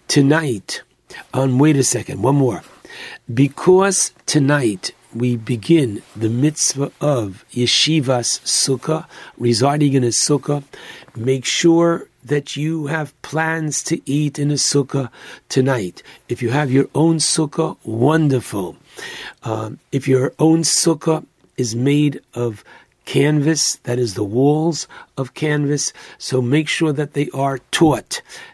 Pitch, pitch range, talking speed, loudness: 140 Hz, 125-155 Hz, 130 wpm, -18 LUFS